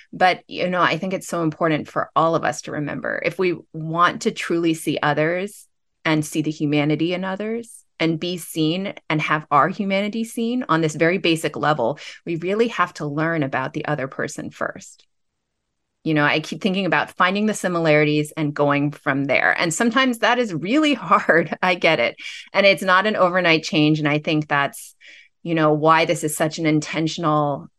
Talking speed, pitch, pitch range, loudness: 195 wpm, 165 Hz, 155-190 Hz, -20 LUFS